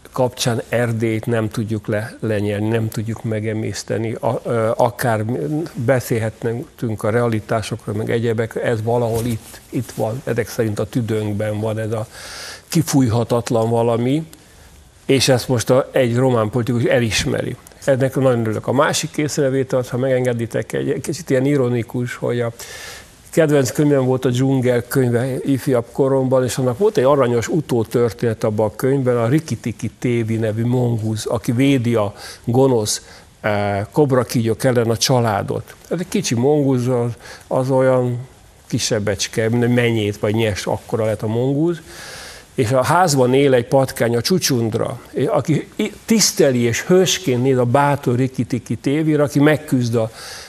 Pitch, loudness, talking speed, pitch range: 120 Hz, -18 LUFS, 140 wpm, 115-135 Hz